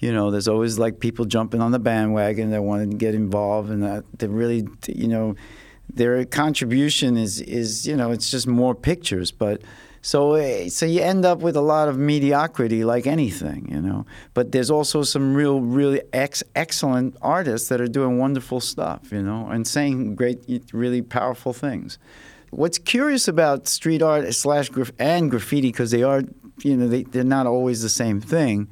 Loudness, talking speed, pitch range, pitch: -21 LUFS, 185 wpm, 115-145 Hz, 125 Hz